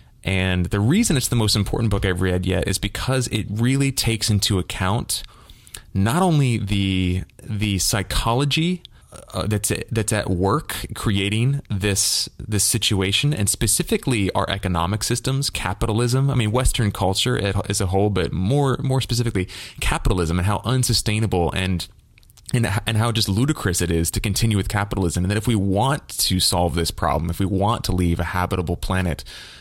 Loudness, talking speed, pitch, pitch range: -21 LUFS, 170 wpm, 105 Hz, 95-120 Hz